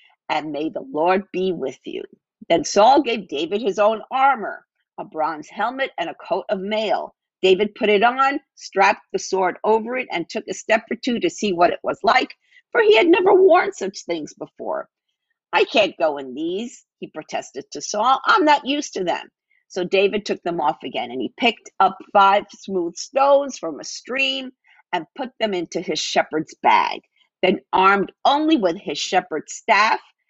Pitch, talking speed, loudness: 235 Hz, 190 wpm, -20 LUFS